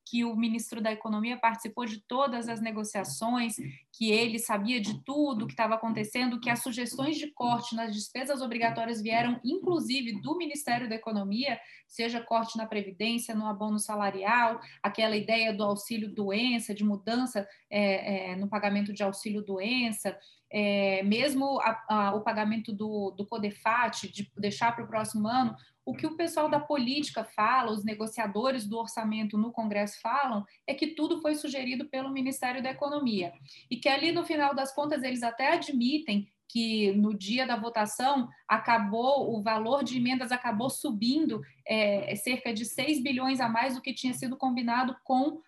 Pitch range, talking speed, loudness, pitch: 215-260 Hz, 165 wpm, -30 LUFS, 230 Hz